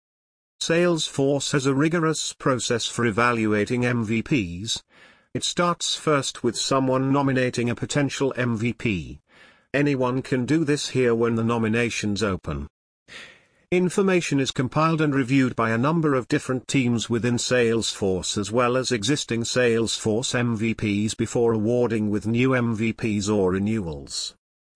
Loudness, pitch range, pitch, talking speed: -23 LUFS, 115-140 Hz, 120 Hz, 125 wpm